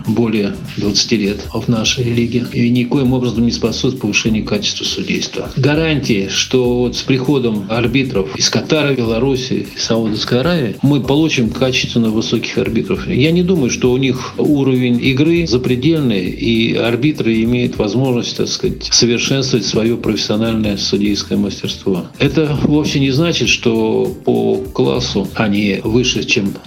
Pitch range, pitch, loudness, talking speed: 115-135 Hz, 120 Hz, -15 LUFS, 135 wpm